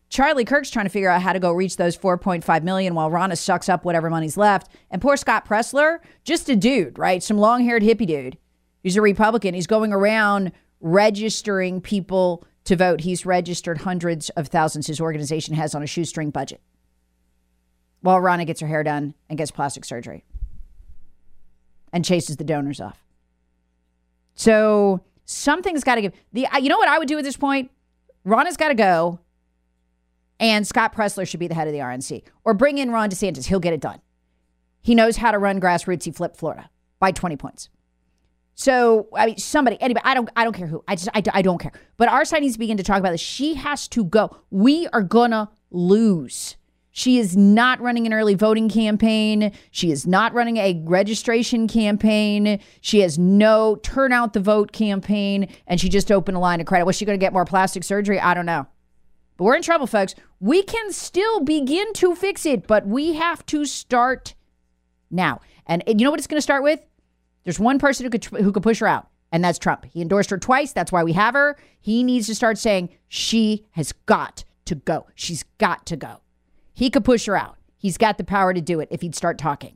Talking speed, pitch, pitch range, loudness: 205 wpm, 195 Hz, 160-225 Hz, -20 LUFS